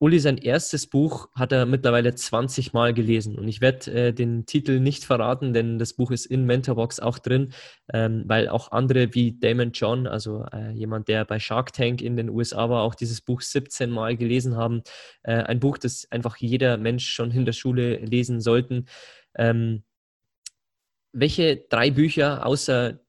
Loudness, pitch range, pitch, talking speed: -23 LUFS, 115-130 Hz, 120 Hz, 180 wpm